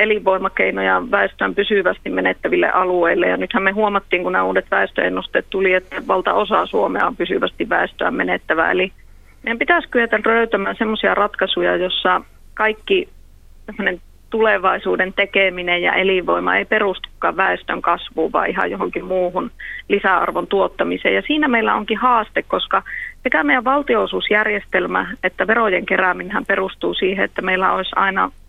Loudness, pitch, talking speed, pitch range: -18 LUFS, 200 Hz, 135 wpm, 185-225 Hz